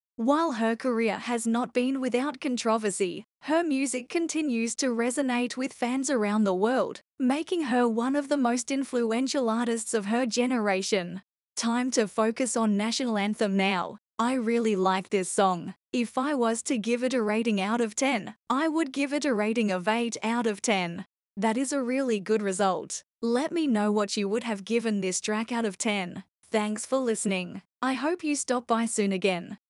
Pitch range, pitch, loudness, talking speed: 210-260 Hz, 230 Hz, -27 LUFS, 185 wpm